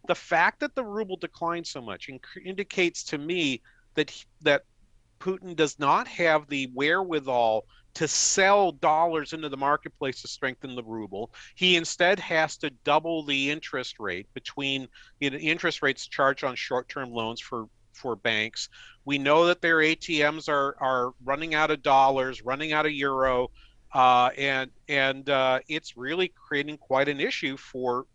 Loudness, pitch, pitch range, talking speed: -26 LUFS, 145 Hz, 130-160 Hz, 165 wpm